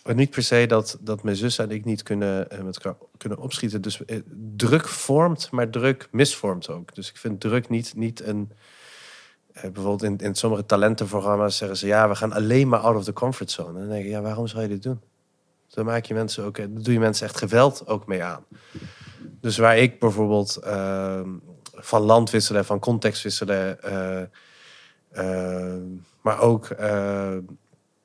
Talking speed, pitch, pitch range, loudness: 180 wpm, 105 Hz, 100-115 Hz, -23 LUFS